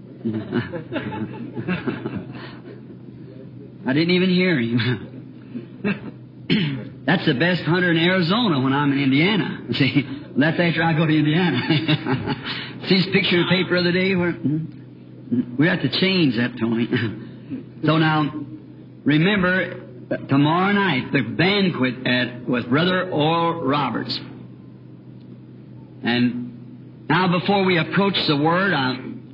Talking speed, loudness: 120 wpm, -20 LUFS